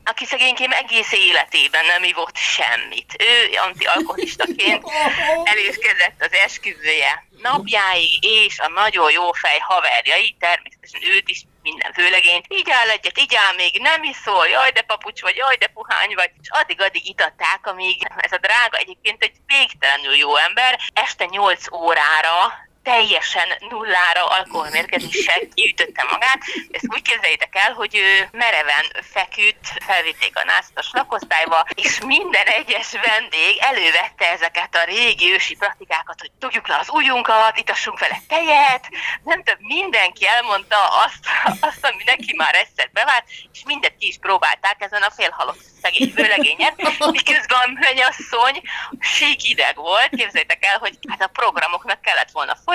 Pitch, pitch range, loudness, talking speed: 240 Hz, 190-305 Hz, -16 LUFS, 140 wpm